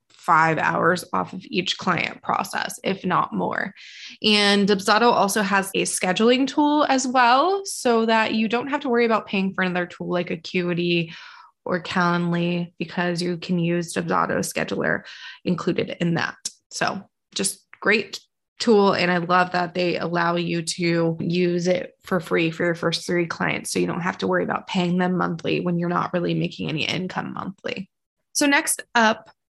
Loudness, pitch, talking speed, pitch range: -22 LUFS, 180 Hz, 175 wpm, 175-220 Hz